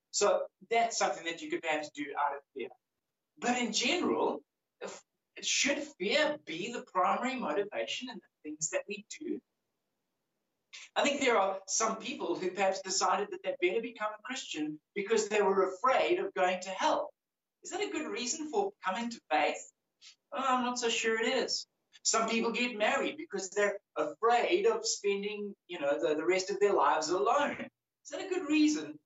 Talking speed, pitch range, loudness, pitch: 185 wpm, 190-285 Hz, -32 LUFS, 225 Hz